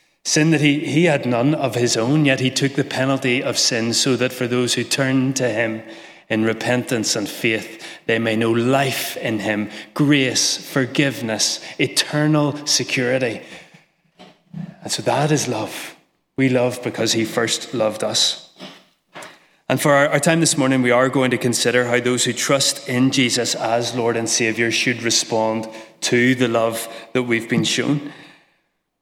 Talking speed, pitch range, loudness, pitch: 165 wpm, 115-140 Hz, -18 LUFS, 125 Hz